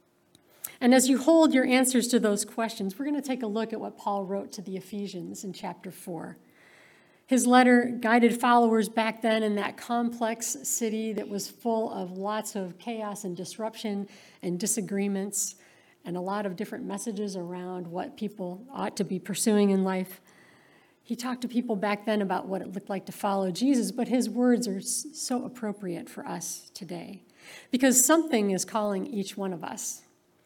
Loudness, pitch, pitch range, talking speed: -27 LUFS, 215 Hz, 195-240 Hz, 180 wpm